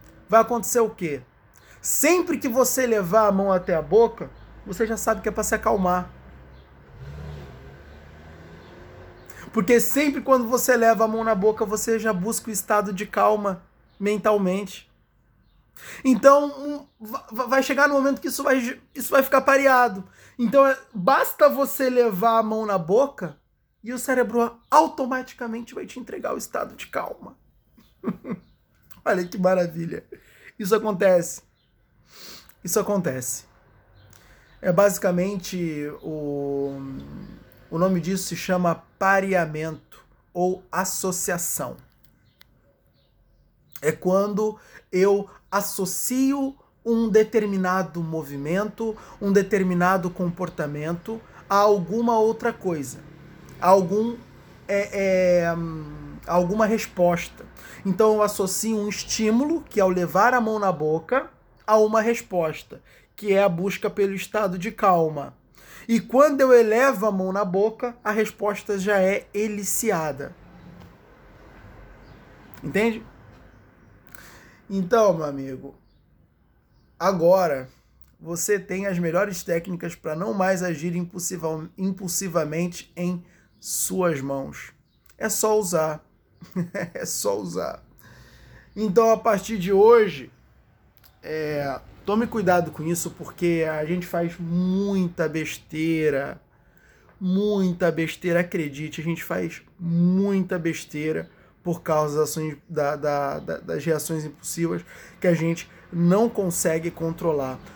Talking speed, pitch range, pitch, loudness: 115 wpm, 165-220 Hz, 190 Hz, -23 LUFS